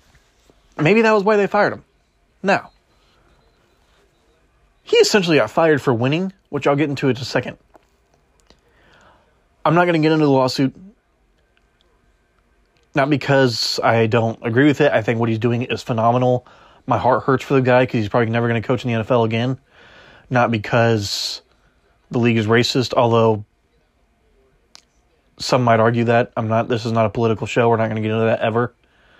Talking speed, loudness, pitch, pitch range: 180 wpm, -18 LUFS, 120 Hz, 115-140 Hz